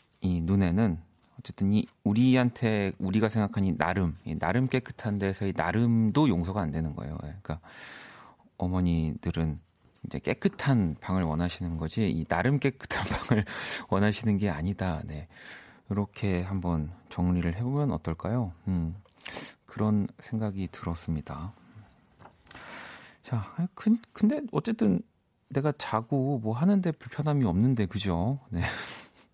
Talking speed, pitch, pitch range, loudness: 270 characters per minute, 100 Hz, 85-120 Hz, -29 LUFS